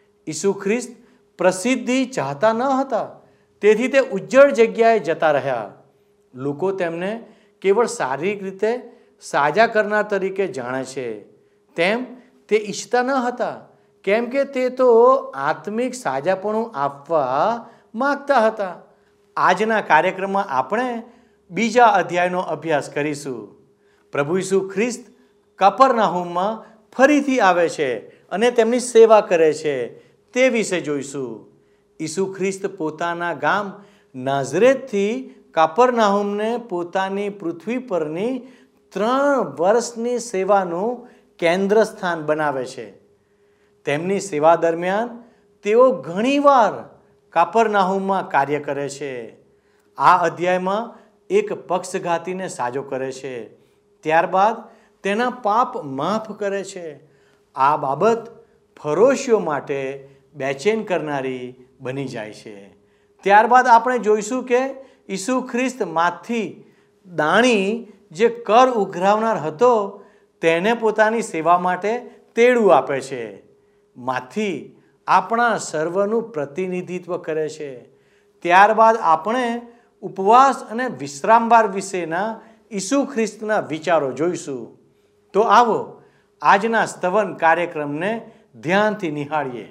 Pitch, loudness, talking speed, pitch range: 205 Hz, -19 LUFS, 95 wpm, 170-230 Hz